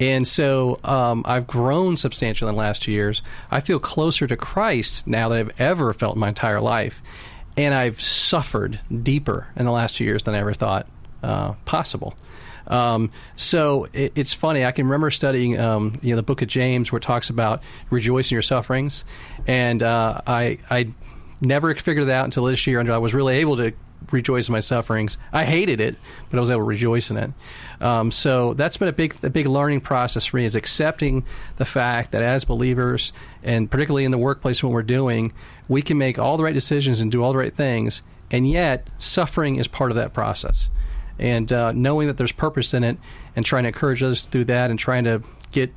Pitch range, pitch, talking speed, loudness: 115-135 Hz, 125 Hz, 215 wpm, -21 LUFS